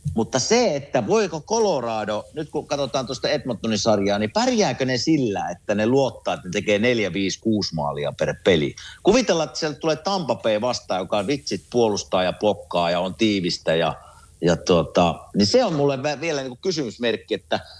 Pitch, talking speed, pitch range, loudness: 125 Hz, 170 wpm, 105-150 Hz, -22 LUFS